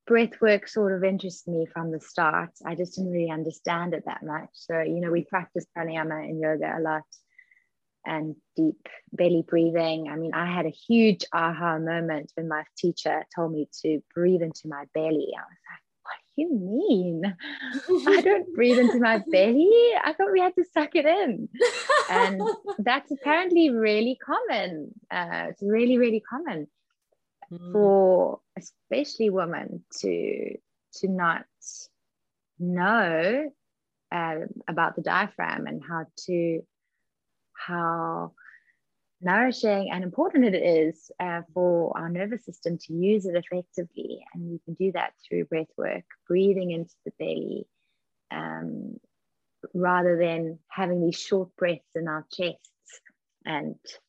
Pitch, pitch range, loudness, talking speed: 180 Hz, 165-235 Hz, -26 LUFS, 145 wpm